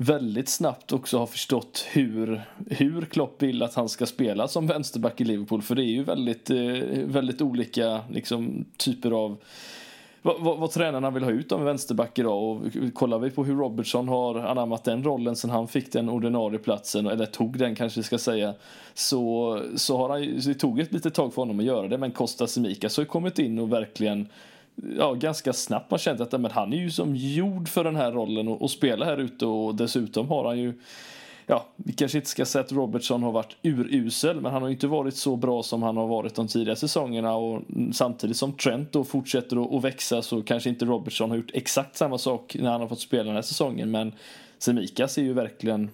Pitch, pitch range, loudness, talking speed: 120 Hz, 115-140 Hz, -27 LUFS, 220 wpm